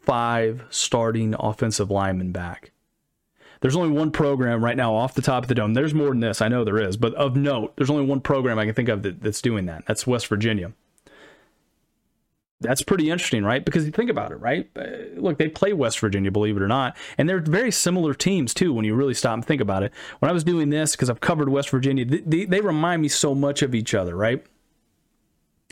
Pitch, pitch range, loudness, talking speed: 130 Hz, 110-150 Hz, -22 LUFS, 225 wpm